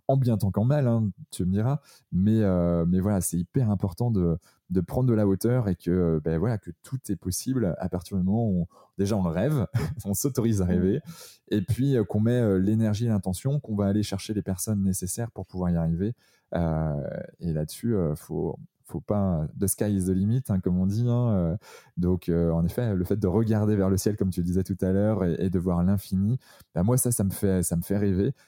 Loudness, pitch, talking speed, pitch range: -26 LUFS, 100 Hz, 250 wpm, 90-110 Hz